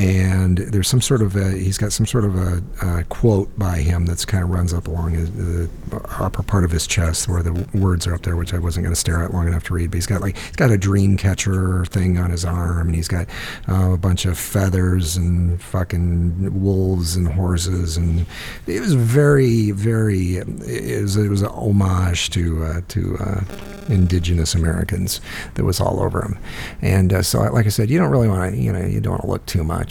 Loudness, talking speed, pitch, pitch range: -19 LUFS, 225 wpm, 95 Hz, 85-100 Hz